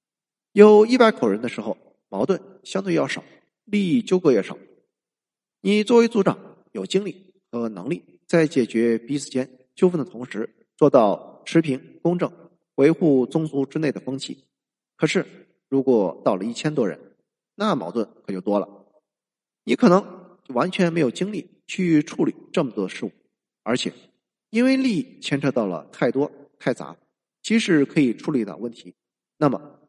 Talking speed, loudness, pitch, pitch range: 235 characters per minute, -22 LUFS, 165 Hz, 130-200 Hz